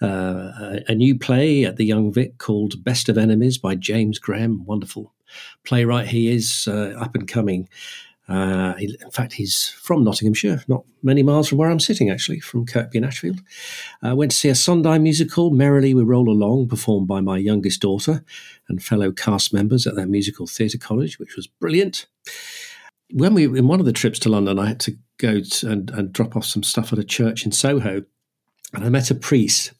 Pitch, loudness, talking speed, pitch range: 115 Hz, -19 LUFS, 205 wpm, 105-130 Hz